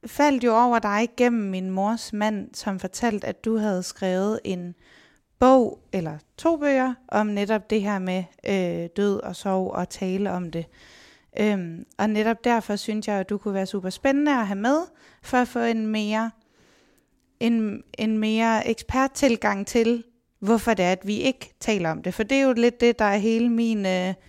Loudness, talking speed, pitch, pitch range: -24 LUFS, 190 wpm, 215 Hz, 195-235 Hz